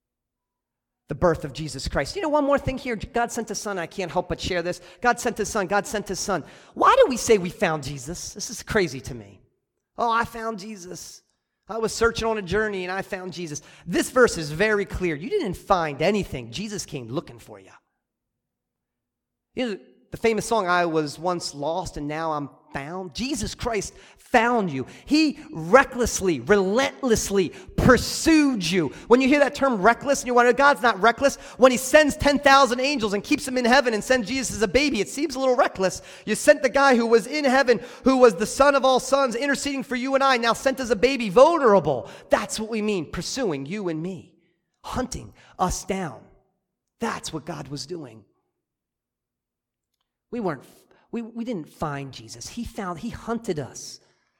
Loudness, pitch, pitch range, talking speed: -22 LUFS, 215 Hz, 175-255 Hz, 195 wpm